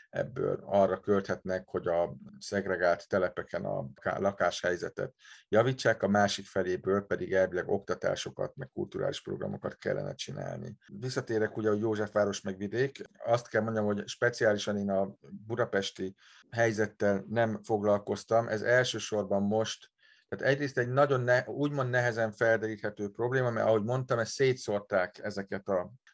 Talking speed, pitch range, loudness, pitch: 130 wpm, 100-120 Hz, -31 LUFS, 105 Hz